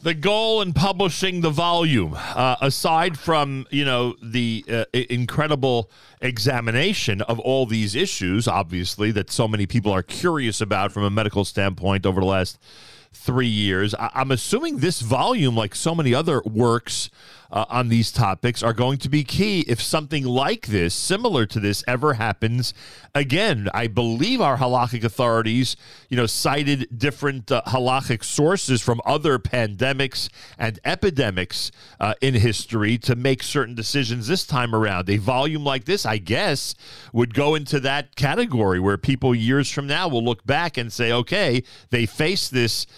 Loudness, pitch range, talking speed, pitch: -22 LUFS, 110-140 Hz, 160 wpm, 125 Hz